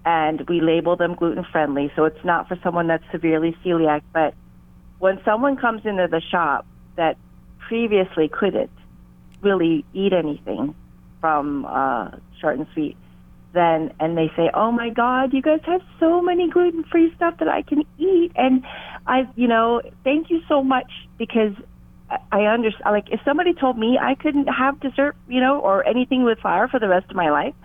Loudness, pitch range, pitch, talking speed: -20 LUFS, 160-260 Hz, 200 Hz, 180 wpm